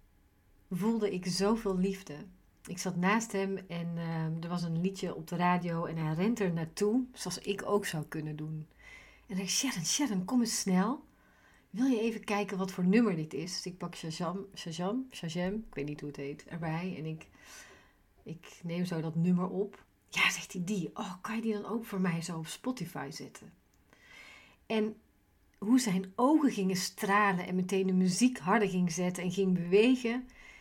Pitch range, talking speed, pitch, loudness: 170-210 Hz, 195 wpm, 190 Hz, -32 LUFS